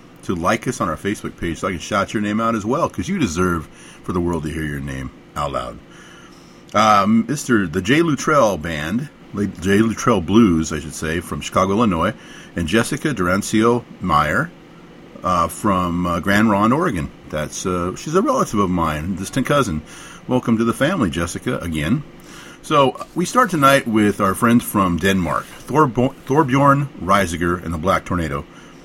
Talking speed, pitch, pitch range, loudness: 175 wpm, 100 Hz, 85-115 Hz, -19 LUFS